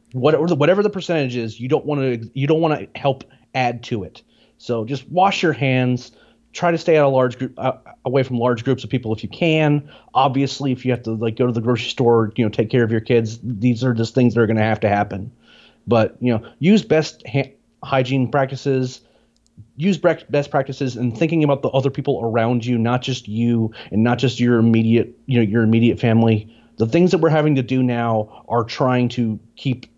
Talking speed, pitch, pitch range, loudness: 220 wpm, 125 Hz, 115-140 Hz, -19 LUFS